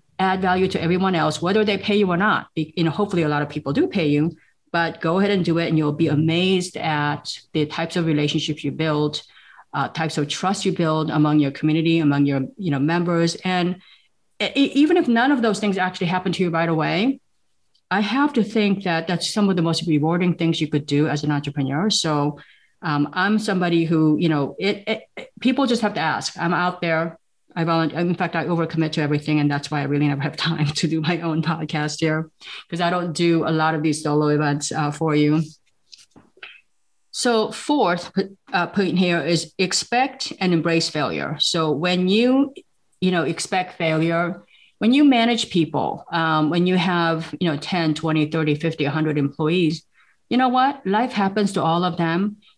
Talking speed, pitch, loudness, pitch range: 205 wpm, 165 Hz, -21 LUFS, 155-190 Hz